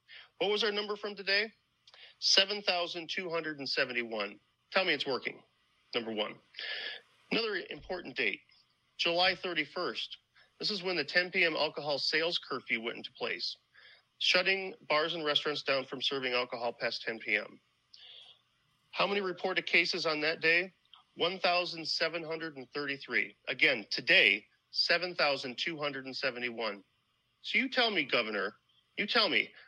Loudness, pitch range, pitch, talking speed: -31 LUFS, 135-185 Hz, 165 Hz, 120 wpm